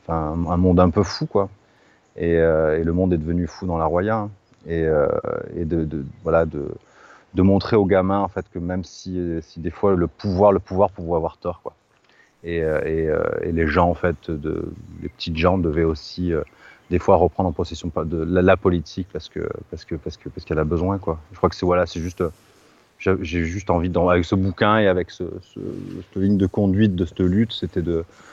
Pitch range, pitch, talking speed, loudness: 85-95 Hz, 90 Hz, 230 wpm, -21 LUFS